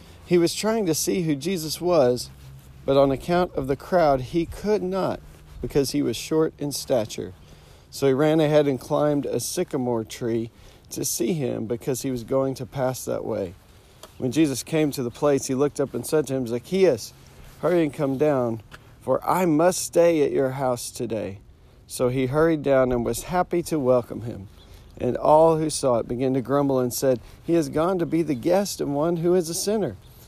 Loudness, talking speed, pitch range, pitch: -23 LUFS, 200 wpm, 120-160 Hz, 135 Hz